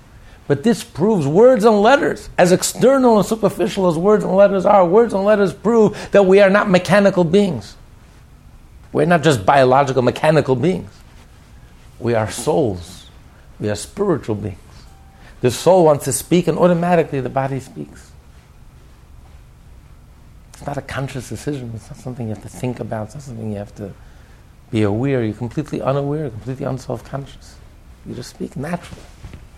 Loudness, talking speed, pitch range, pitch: -16 LUFS, 160 wpm, 110-180 Hz, 135 Hz